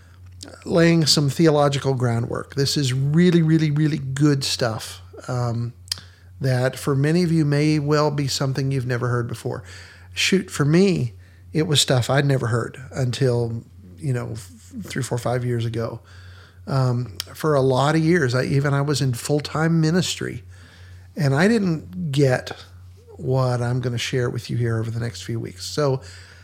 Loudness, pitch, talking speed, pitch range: -21 LUFS, 125 Hz, 170 wpm, 110-145 Hz